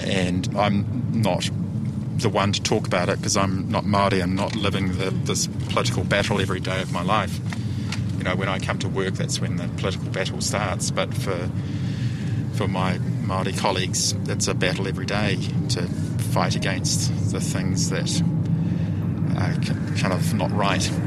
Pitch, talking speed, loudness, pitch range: 105 Hz, 170 wpm, -23 LUFS, 95-130 Hz